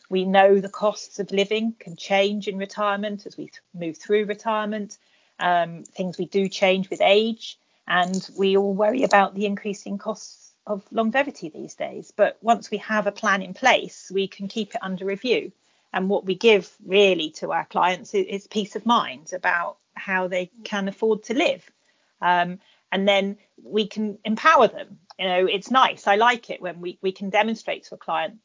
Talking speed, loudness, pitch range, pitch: 190 wpm, -23 LUFS, 190-215 Hz, 200 Hz